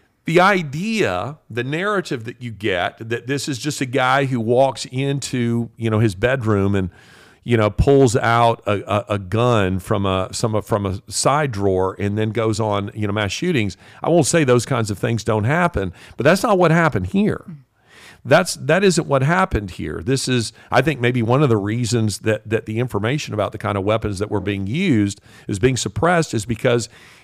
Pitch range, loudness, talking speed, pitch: 105-140 Hz, -19 LUFS, 205 wpm, 115 Hz